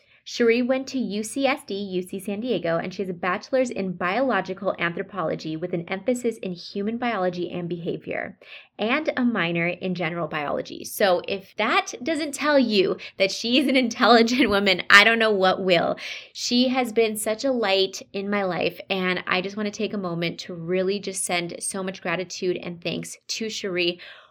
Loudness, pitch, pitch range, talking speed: -23 LUFS, 195 Hz, 180-235 Hz, 185 wpm